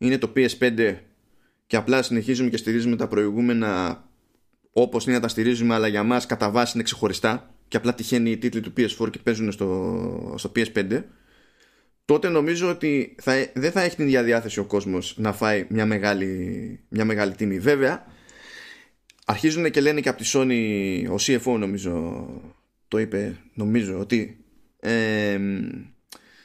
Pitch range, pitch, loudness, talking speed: 105-125 Hz, 115 Hz, -23 LUFS, 155 wpm